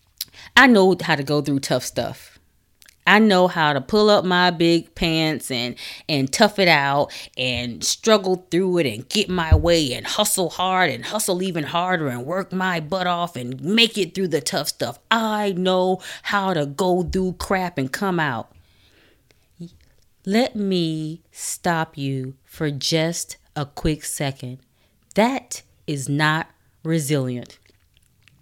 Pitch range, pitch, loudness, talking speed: 140-185 Hz, 165 Hz, -20 LUFS, 150 wpm